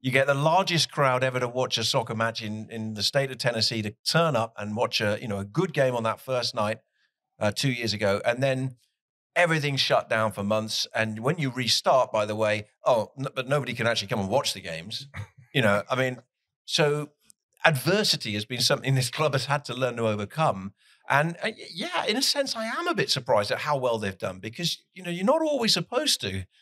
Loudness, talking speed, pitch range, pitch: -26 LUFS, 230 wpm, 110-150 Hz, 130 Hz